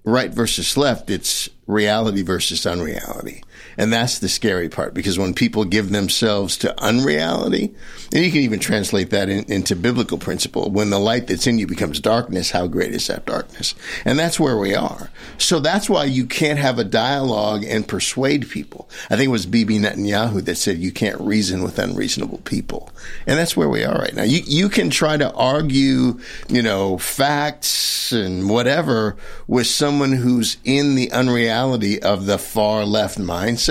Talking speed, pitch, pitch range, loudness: 180 wpm, 110 Hz, 100-130 Hz, -19 LUFS